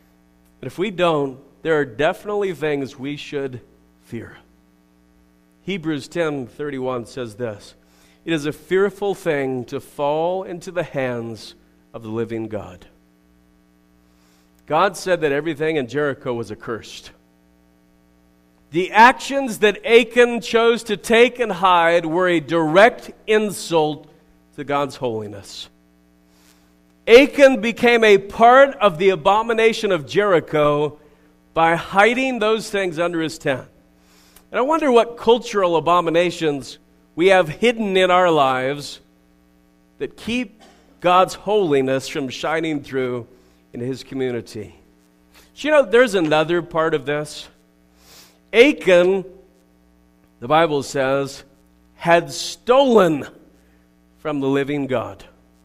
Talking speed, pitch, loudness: 120 wpm, 145 Hz, -18 LUFS